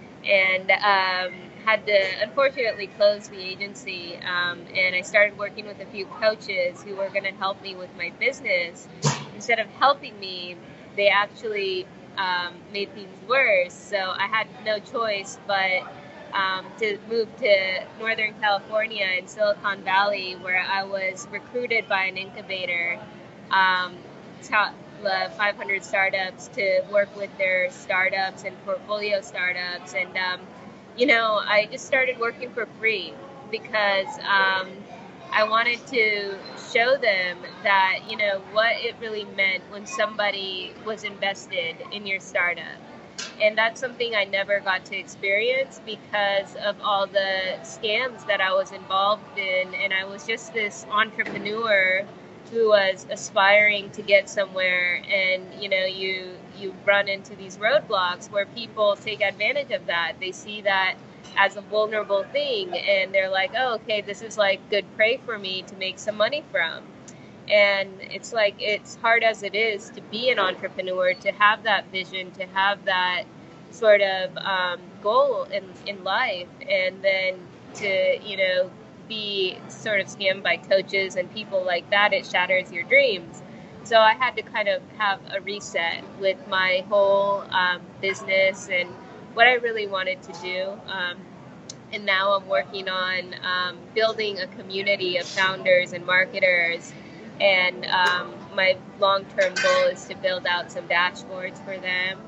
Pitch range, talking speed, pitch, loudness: 185-215 Hz, 155 wpm, 195 Hz, -23 LUFS